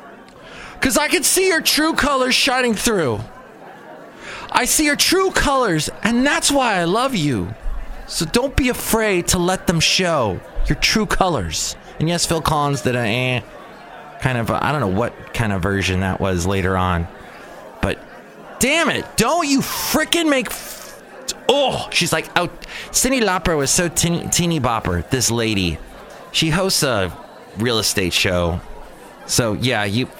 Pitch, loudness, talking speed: 170 Hz, -18 LUFS, 165 wpm